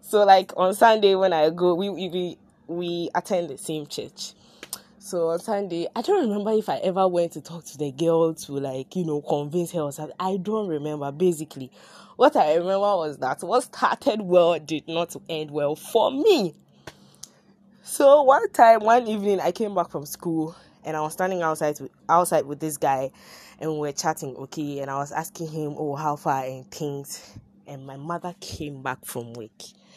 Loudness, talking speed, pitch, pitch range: -23 LUFS, 195 wpm, 170 Hz, 150-190 Hz